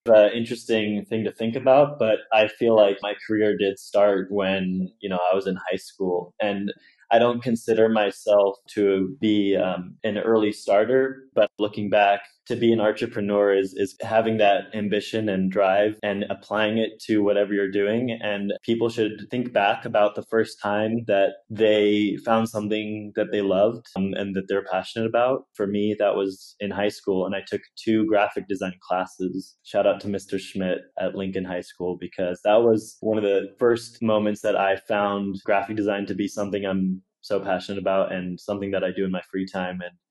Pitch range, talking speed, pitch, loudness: 95-110 Hz, 195 wpm, 105 Hz, -23 LUFS